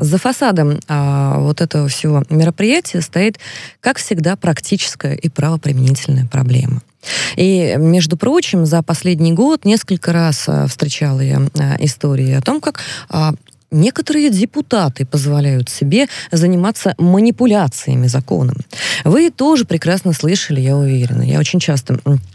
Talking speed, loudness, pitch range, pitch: 125 wpm, -14 LUFS, 140-190 Hz, 160 Hz